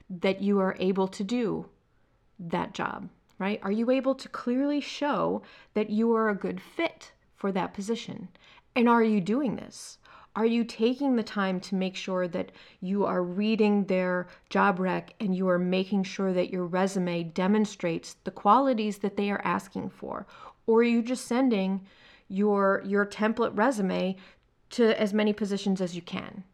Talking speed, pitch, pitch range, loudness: 170 wpm, 205 Hz, 190-225 Hz, -28 LUFS